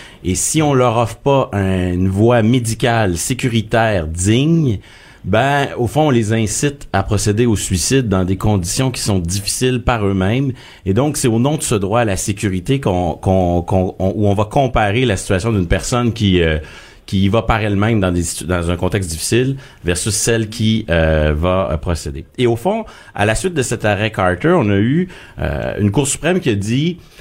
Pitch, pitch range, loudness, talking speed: 110 Hz, 95-125 Hz, -16 LUFS, 200 wpm